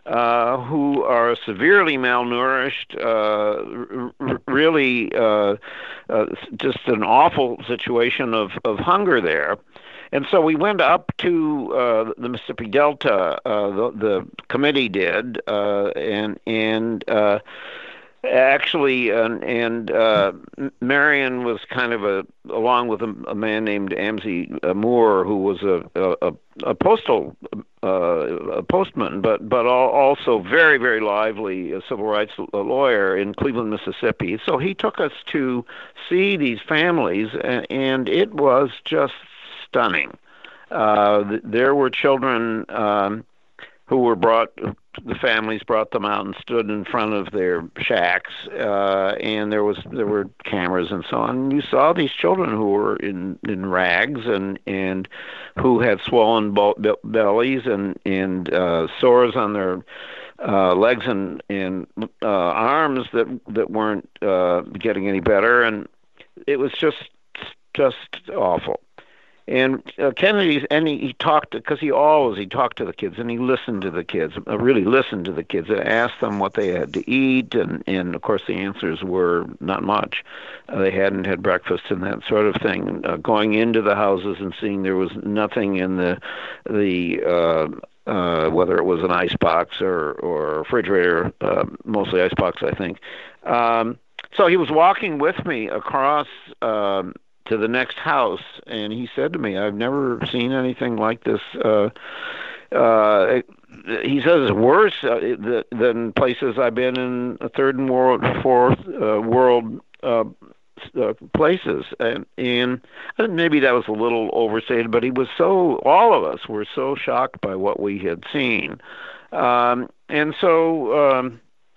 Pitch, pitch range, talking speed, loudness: 115 Hz, 105-130 Hz, 155 wpm, -20 LUFS